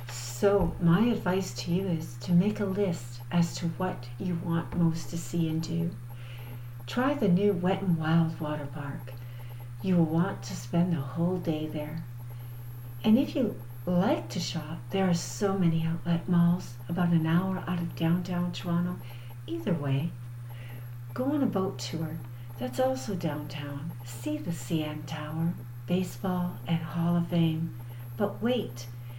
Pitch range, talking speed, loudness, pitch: 120-175 Hz, 160 wpm, -30 LUFS, 160 Hz